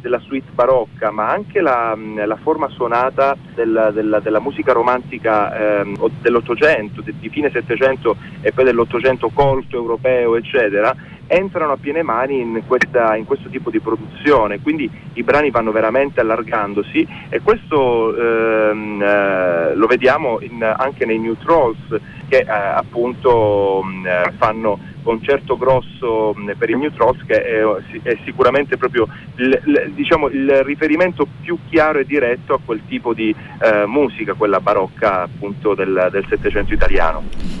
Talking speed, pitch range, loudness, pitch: 145 wpm, 110-140 Hz, -17 LUFS, 120 Hz